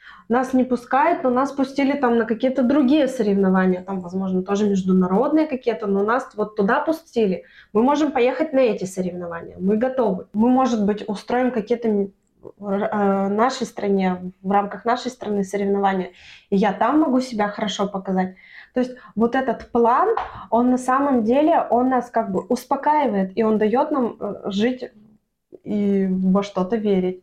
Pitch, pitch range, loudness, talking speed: 220 Hz, 200-255 Hz, -21 LUFS, 160 wpm